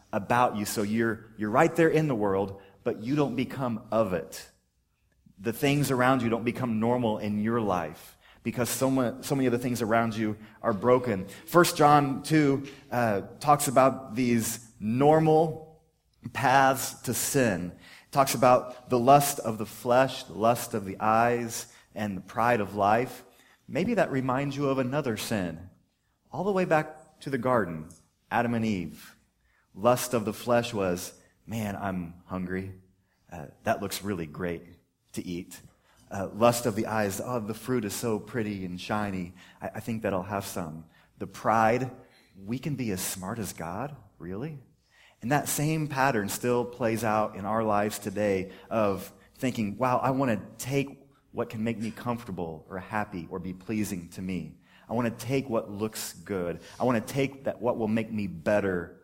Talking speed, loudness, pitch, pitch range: 175 wpm, -28 LUFS, 115 Hz, 100-130 Hz